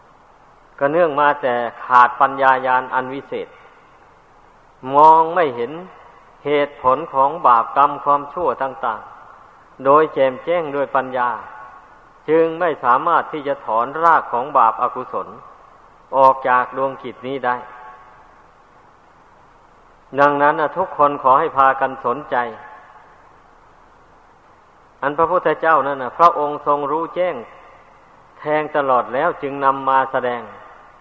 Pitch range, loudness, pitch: 125-150 Hz, -17 LUFS, 135 Hz